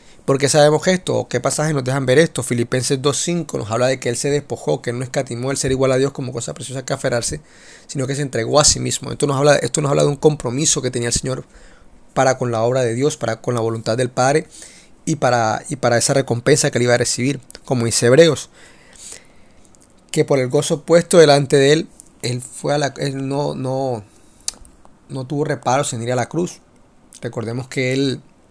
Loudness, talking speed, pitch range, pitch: -18 LUFS, 220 wpm, 120-145 Hz, 130 Hz